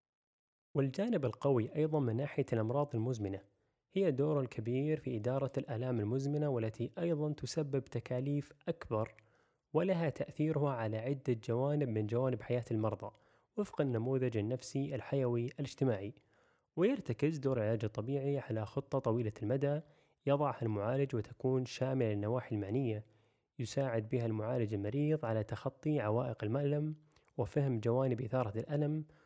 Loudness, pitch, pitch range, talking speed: -36 LUFS, 130 Hz, 115-145 Hz, 120 wpm